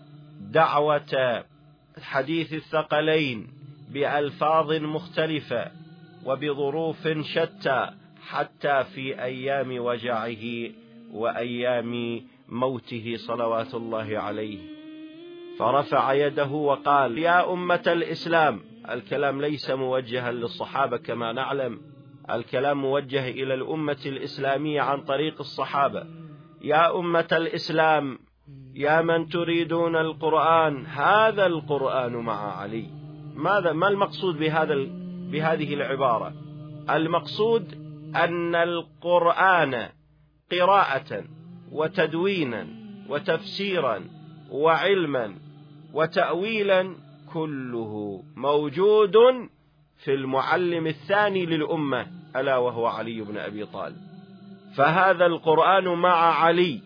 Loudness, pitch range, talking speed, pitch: -24 LUFS, 135-170 Hz, 80 wpm, 150 Hz